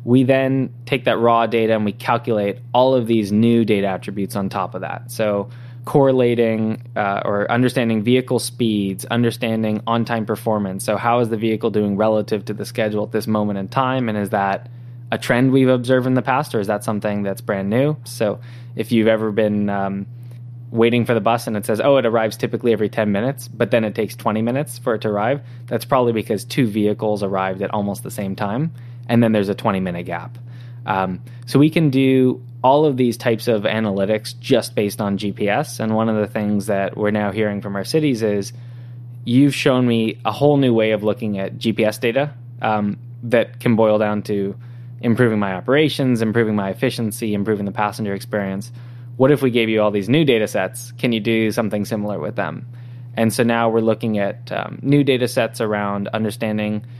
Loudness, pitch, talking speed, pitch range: -19 LUFS, 115 Hz, 205 wpm, 105-120 Hz